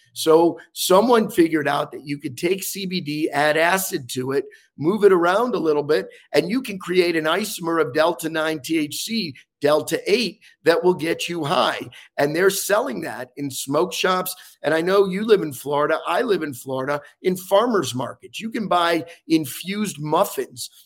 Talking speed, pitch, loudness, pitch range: 180 wpm, 165 Hz, -21 LUFS, 150-195 Hz